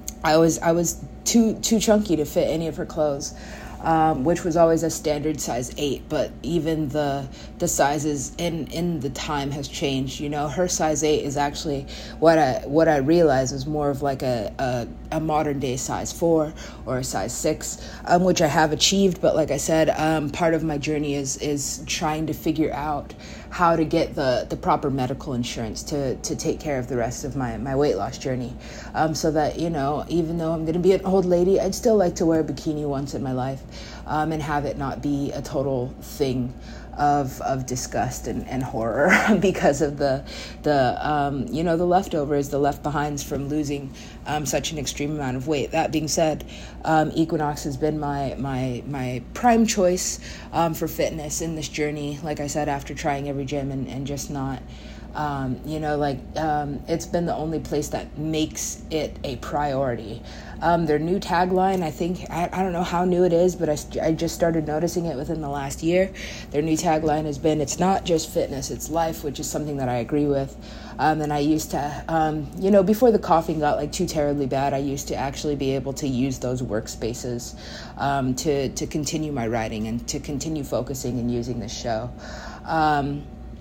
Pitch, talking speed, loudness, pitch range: 150 Hz, 210 wpm, -23 LUFS, 140-165 Hz